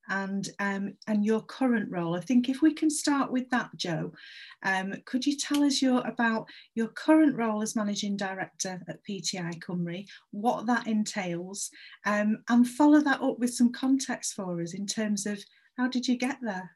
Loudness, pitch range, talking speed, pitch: -28 LUFS, 200-255 Hz, 185 wpm, 220 Hz